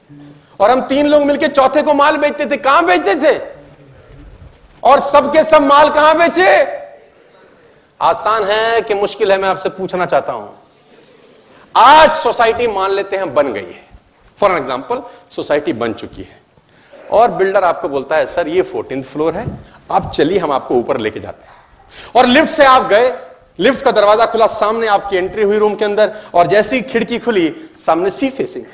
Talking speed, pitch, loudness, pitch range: 175 wpm, 240 Hz, -12 LUFS, 200-295 Hz